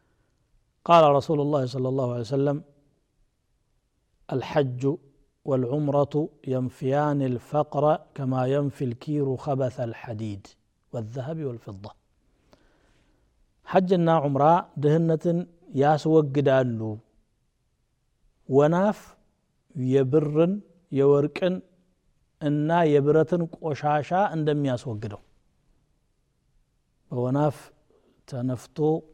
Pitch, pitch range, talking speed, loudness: 145 Hz, 130-155 Hz, 70 wpm, -24 LUFS